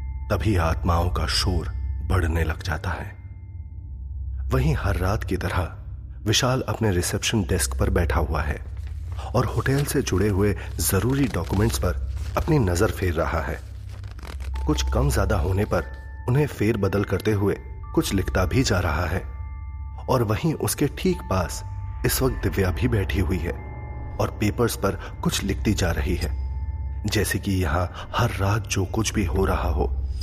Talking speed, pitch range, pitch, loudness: 160 wpm, 80-105 Hz, 95 Hz, -24 LUFS